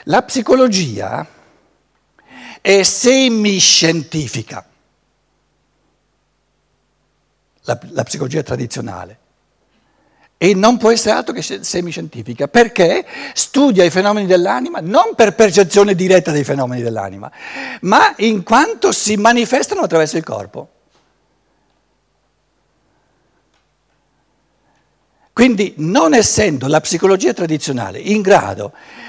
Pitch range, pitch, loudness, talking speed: 140-220 Hz, 185 Hz, -13 LUFS, 85 wpm